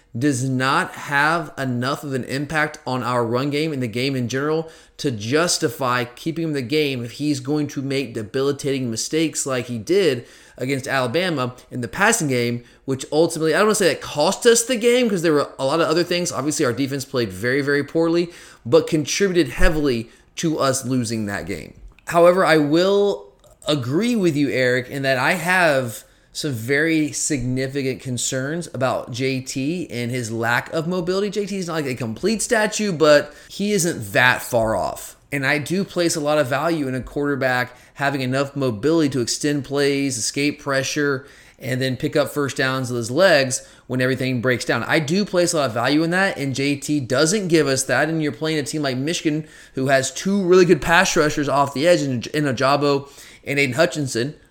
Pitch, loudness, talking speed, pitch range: 140 Hz, -20 LUFS, 195 wpm, 130-160 Hz